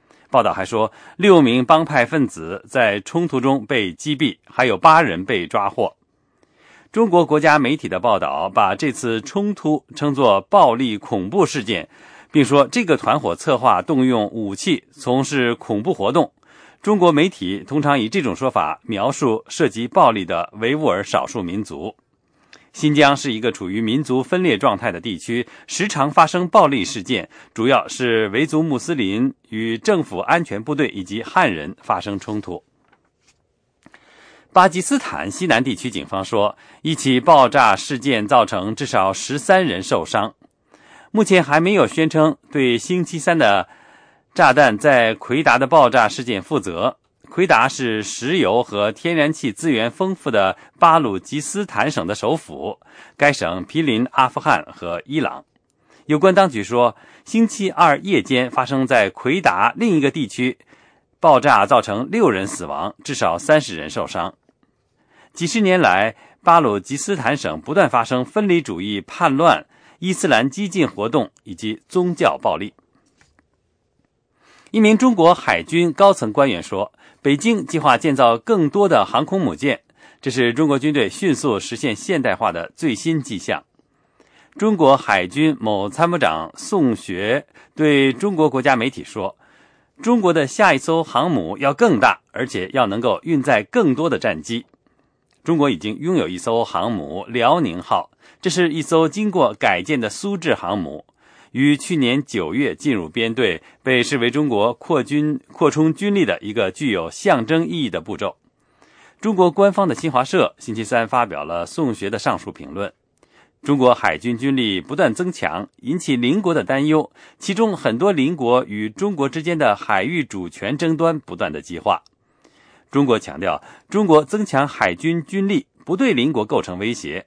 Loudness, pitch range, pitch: -18 LUFS, 120-175 Hz, 150 Hz